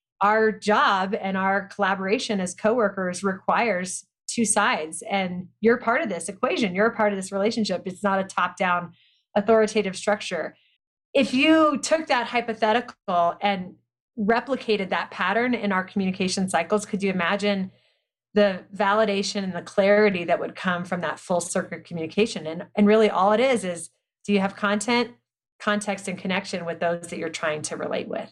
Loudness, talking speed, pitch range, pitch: -24 LUFS, 170 wpm, 180-215 Hz, 200 Hz